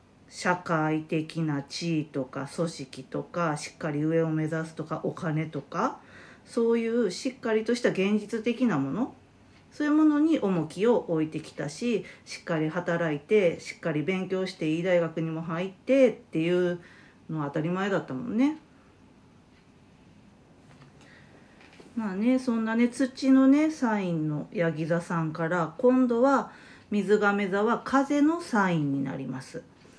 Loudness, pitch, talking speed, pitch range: -27 LUFS, 180 Hz, 275 characters per minute, 160-230 Hz